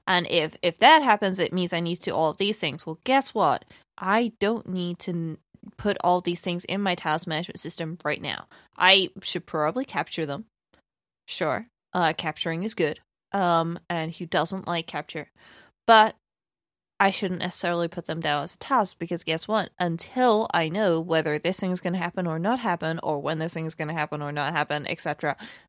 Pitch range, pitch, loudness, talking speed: 160-195 Hz, 175 Hz, -25 LUFS, 205 wpm